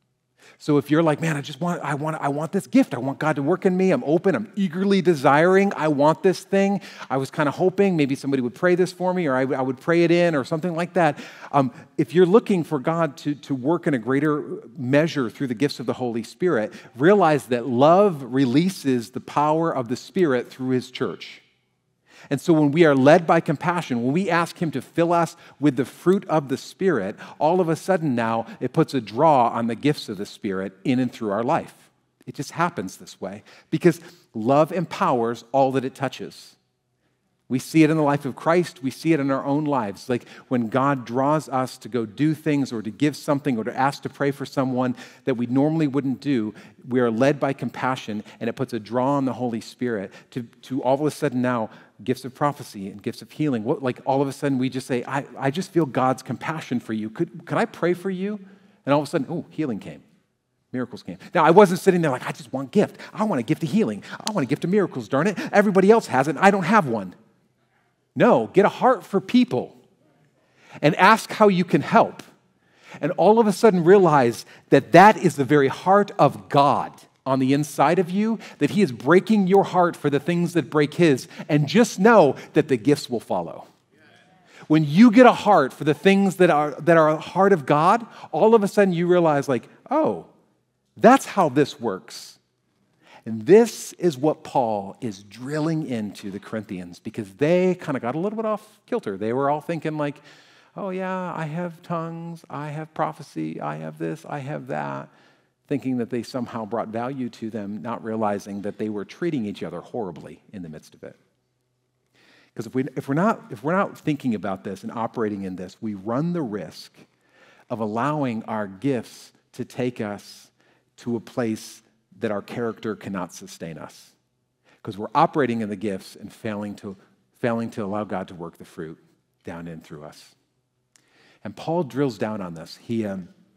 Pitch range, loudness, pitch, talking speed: 125-175 Hz, -22 LUFS, 145 Hz, 215 wpm